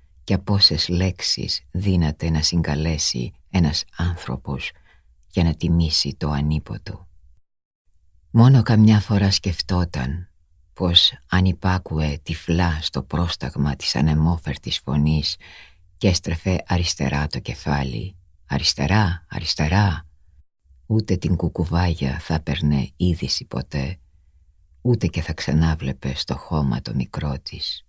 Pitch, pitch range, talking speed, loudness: 80 Hz, 75-90 Hz, 110 wpm, -21 LUFS